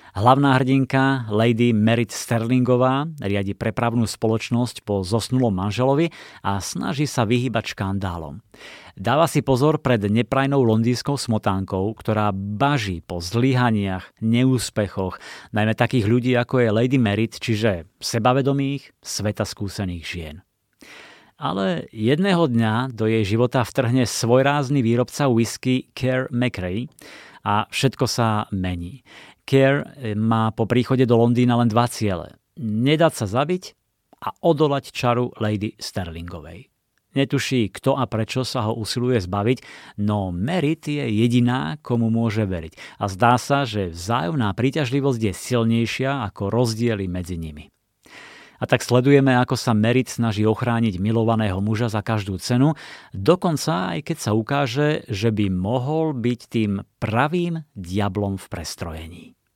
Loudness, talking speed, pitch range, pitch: -21 LUFS, 130 wpm, 105-130 Hz, 115 Hz